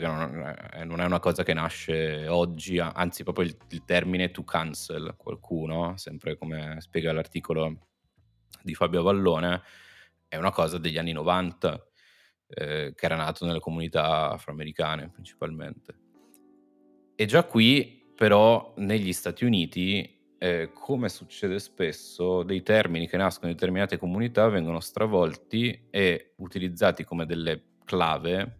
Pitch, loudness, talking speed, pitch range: 85 Hz, -27 LUFS, 130 wpm, 80-95 Hz